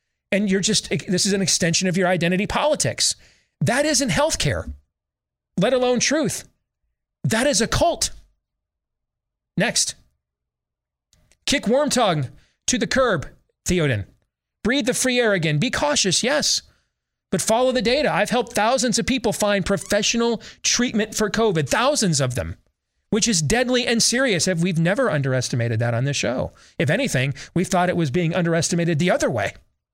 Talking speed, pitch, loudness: 155 wpm, 185 Hz, -20 LUFS